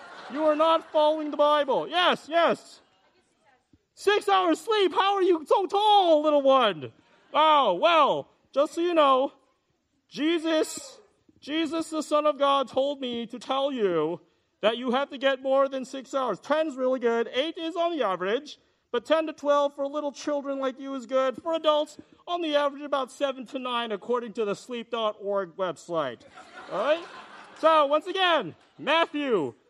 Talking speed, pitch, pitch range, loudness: 170 wpm, 290 Hz, 260-320 Hz, -25 LUFS